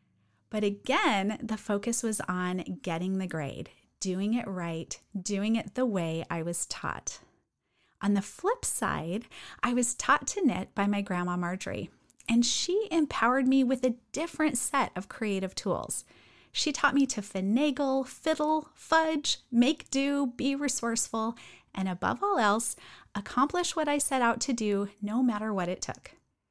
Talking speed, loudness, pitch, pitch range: 160 wpm, -30 LUFS, 230 Hz, 195-275 Hz